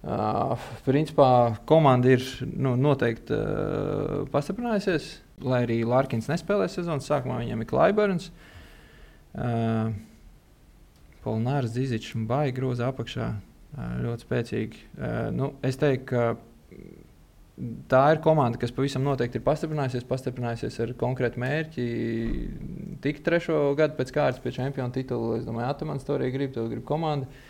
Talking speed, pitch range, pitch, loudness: 130 wpm, 120-150 Hz, 130 Hz, -26 LUFS